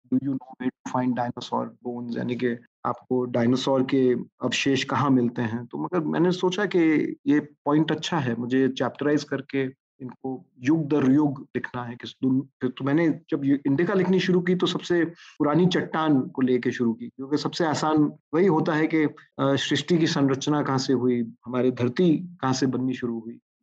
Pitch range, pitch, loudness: 125-155 Hz, 135 Hz, -24 LUFS